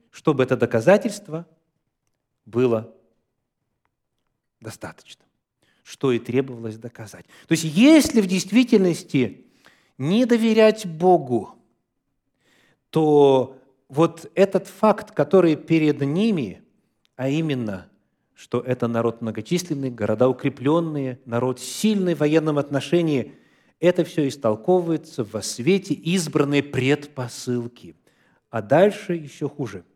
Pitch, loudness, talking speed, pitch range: 145 Hz, -21 LUFS, 95 wpm, 125-175 Hz